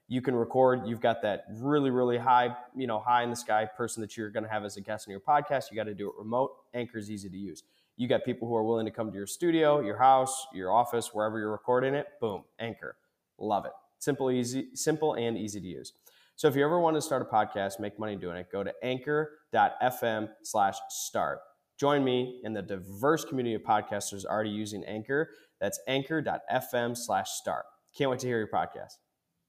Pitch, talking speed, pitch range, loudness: 120 Hz, 220 wpm, 105-135 Hz, -30 LUFS